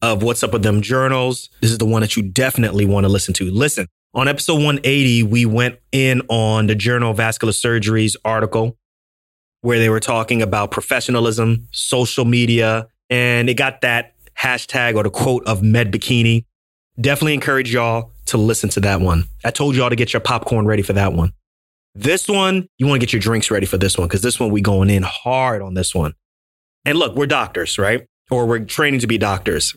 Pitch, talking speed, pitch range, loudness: 115 Hz, 205 wpm, 105-125 Hz, -17 LUFS